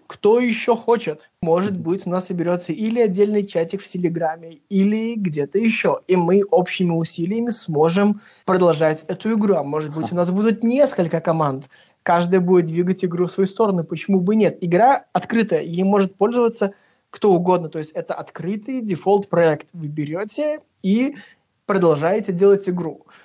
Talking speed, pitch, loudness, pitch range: 155 wpm, 185 Hz, -20 LUFS, 170-205 Hz